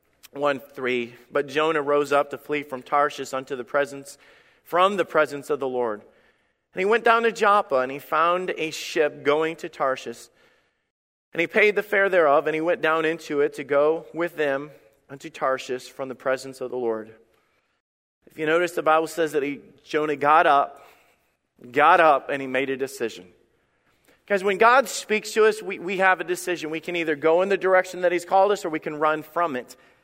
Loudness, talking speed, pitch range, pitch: -23 LUFS, 205 wpm, 140-175 Hz, 155 Hz